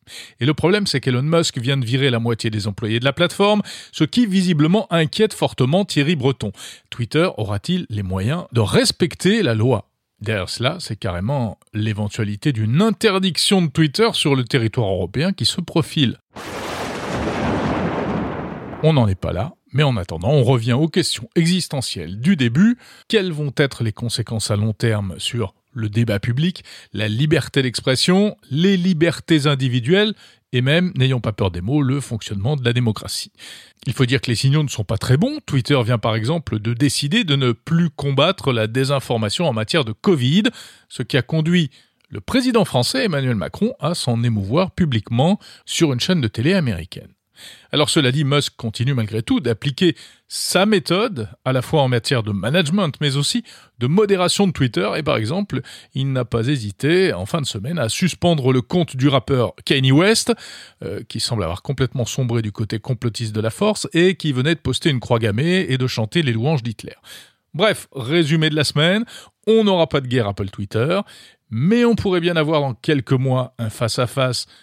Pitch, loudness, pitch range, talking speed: 135 Hz, -19 LUFS, 115-170 Hz, 185 wpm